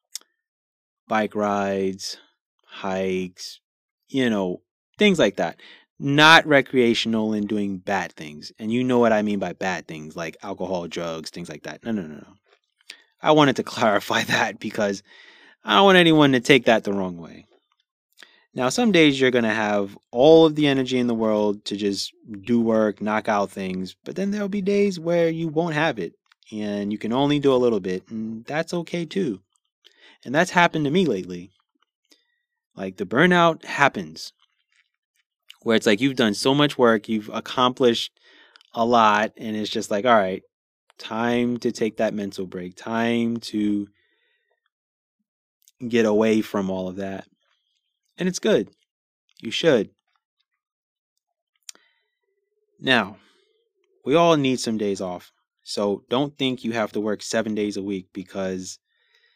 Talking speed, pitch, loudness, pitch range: 160 wpm, 115 Hz, -21 LUFS, 100-165 Hz